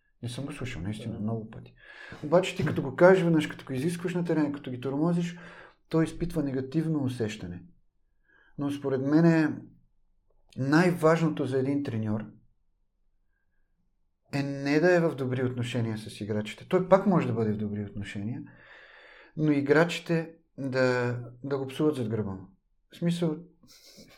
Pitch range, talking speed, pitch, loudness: 110-160 Hz, 150 wpm, 135 Hz, -28 LUFS